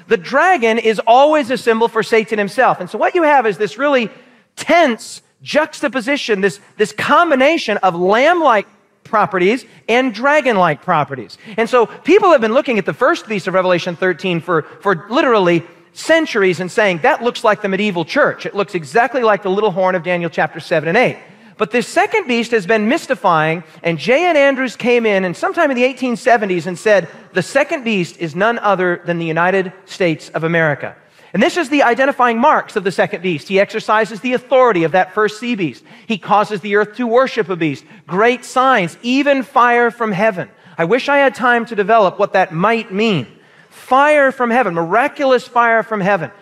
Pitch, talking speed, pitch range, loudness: 220 Hz, 195 wpm, 185-255 Hz, -15 LUFS